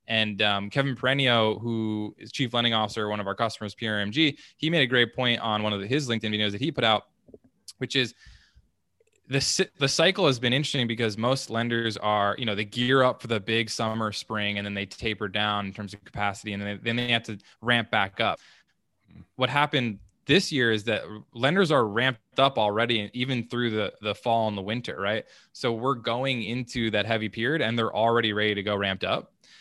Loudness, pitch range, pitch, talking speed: -26 LUFS, 105-125 Hz, 115 Hz, 215 wpm